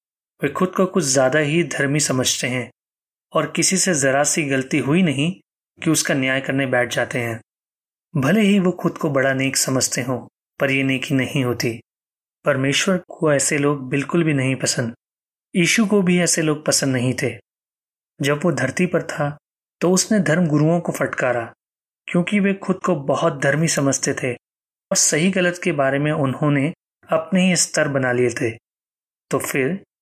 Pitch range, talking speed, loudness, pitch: 135-175 Hz, 175 wpm, -19 LUFS, 150 Hz